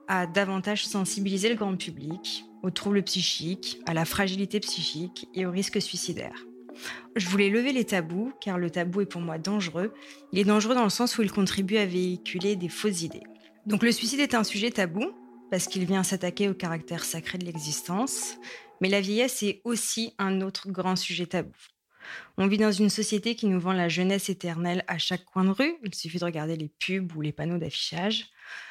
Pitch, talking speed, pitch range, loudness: 190 Hz, 200 wpm, 175-210 Hz, -28 LUFS